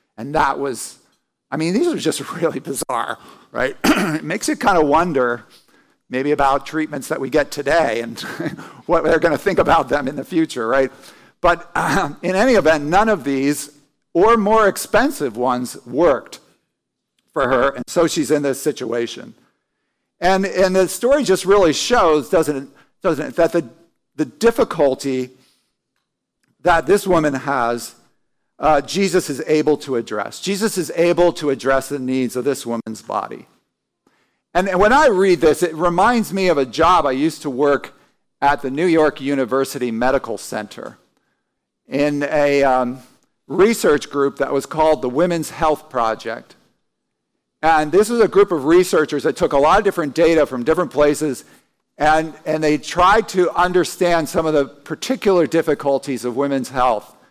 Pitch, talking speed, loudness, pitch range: 150 Hz, 165 wpm, -18 LUFS, 135-175 Hz